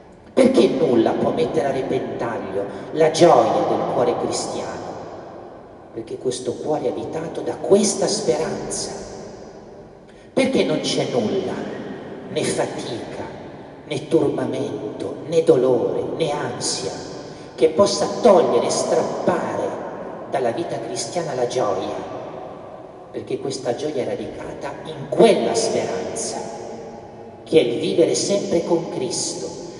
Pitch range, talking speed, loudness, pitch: 160-200 Hz, 110 wpm, -21 LUFS, 170 Hz